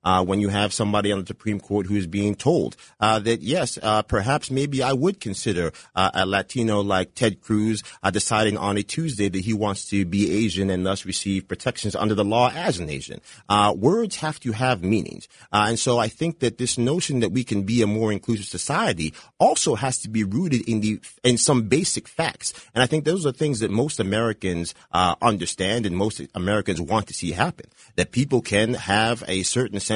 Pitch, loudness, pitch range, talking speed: 110 Hz, -23 LUFS, 100-125 Hz, 210 wpm